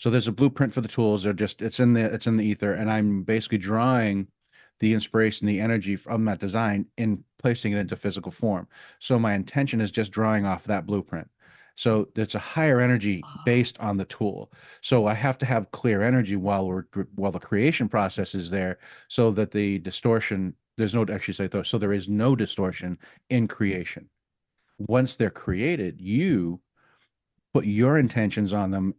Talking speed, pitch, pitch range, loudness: 190 wpm, 105 Hz, 100-115 Hz, -25 LUFS